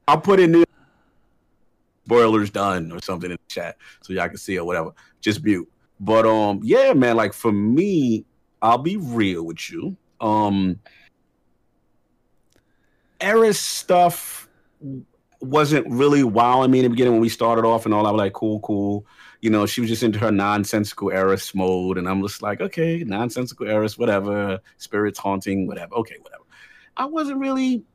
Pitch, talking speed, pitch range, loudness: 110 Hz, 170 wpm, 100-135 Hz, -20 LUFS